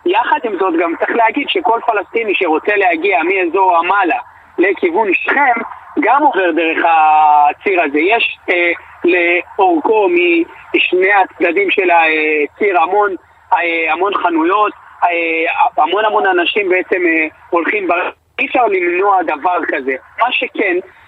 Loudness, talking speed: -13 LUFS, 130 wpm